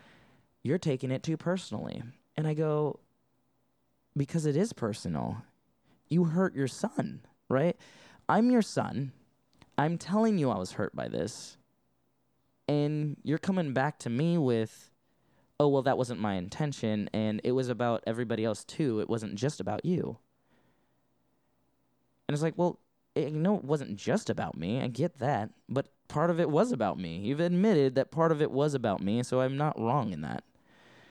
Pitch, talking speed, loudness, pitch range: 140 Hz, 175 wpm, -31 LUFS, 120-160 Hz